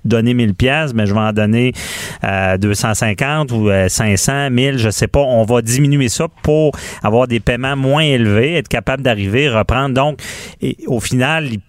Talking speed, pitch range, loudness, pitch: 180 wpm, 110-140 Hz, -14 LUFS, 120 Hz